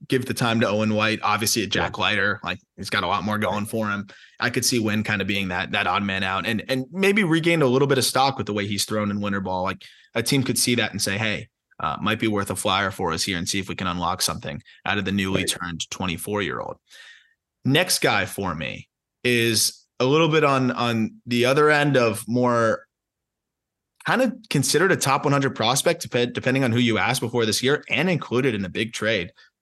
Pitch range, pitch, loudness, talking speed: 100-130 Hz, 115 Hz, -22 LUFS, 235 wpm